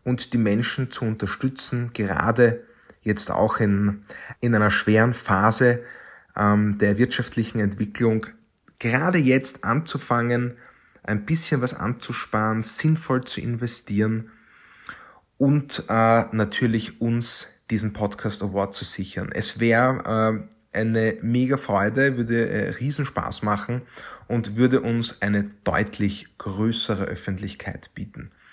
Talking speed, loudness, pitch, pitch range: 115 wpm, -23 LUFS, 115 Hz, 105-125 Hz